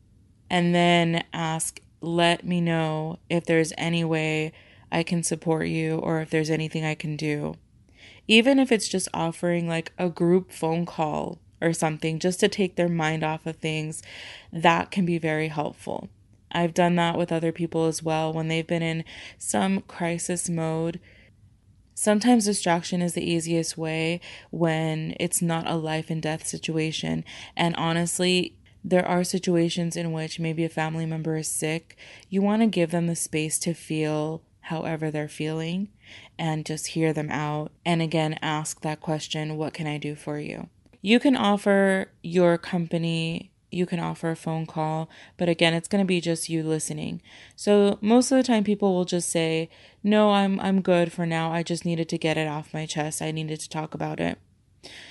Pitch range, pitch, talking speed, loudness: 155-175 Hz, 165 Hz, 180 wpm, -25 LUFS